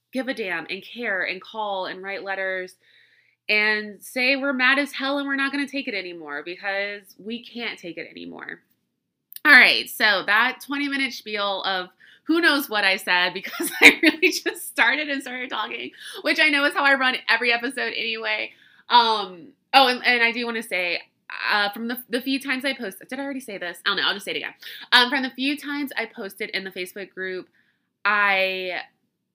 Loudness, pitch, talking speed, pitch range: -21 LUFS, 230 Hz, 210 wpm, 195-275 Hz